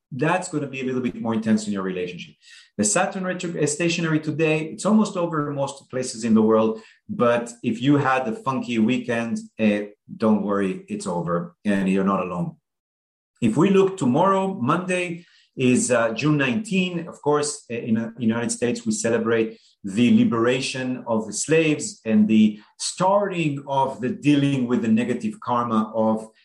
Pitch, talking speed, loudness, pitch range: 125 Hz, 170 wpm, -22 LUFS, 110-155 Hz